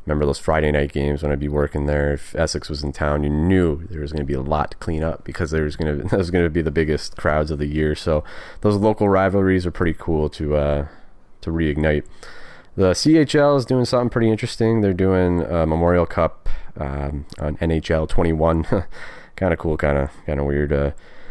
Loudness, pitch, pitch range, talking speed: -20 LUFS, 80 Hz, 75-90 Hz, 225 wpm